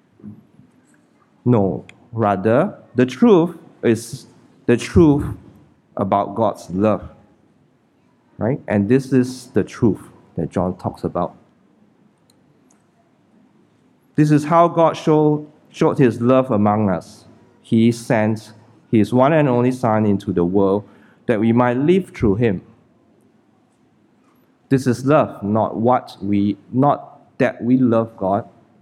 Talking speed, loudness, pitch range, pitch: 120 wpm, -18 LUFS, 105-135 Hz, 120 Hz